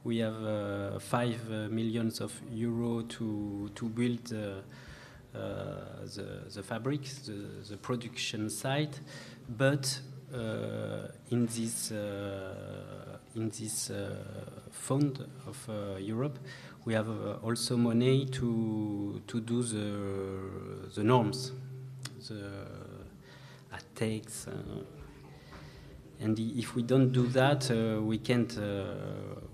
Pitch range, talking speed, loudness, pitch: 105-130 Hz, 115 wpm, -34 LUFS, 115 Hz